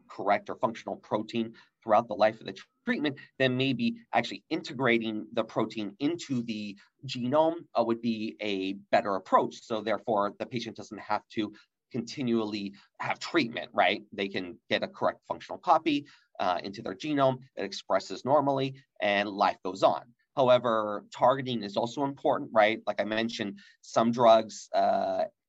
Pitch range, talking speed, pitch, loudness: 110-140 Hz, 155 wpm, 120 Hz, -29 LUFS